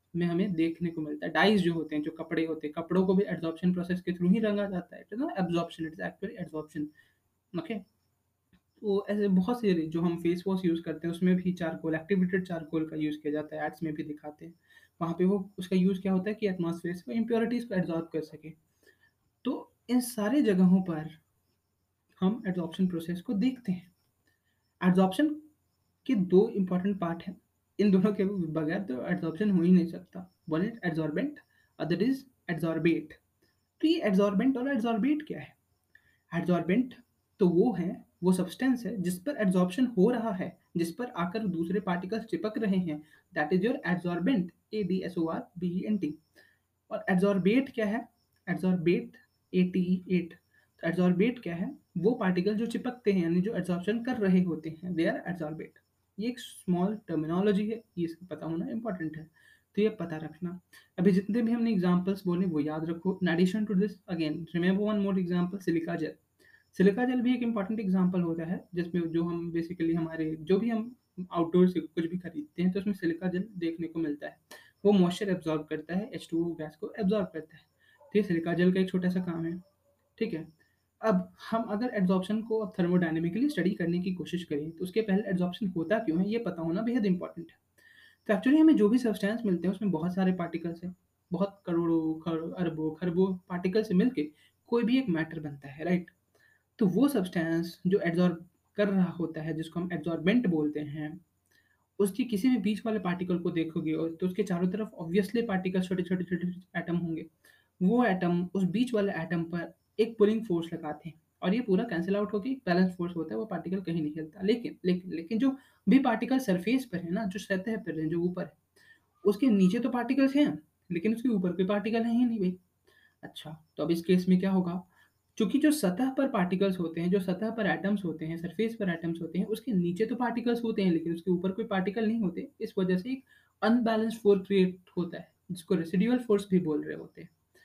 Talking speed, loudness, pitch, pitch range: 185 wpm, -30 LUFS, 185 Hz, 165-210 Hz